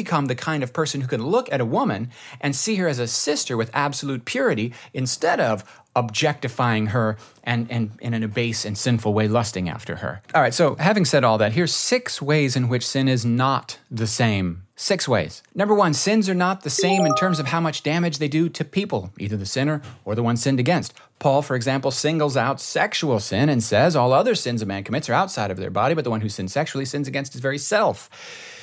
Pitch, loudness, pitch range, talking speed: 135 Hz, -22 LUFS, 115-155 Hz, 235 wpm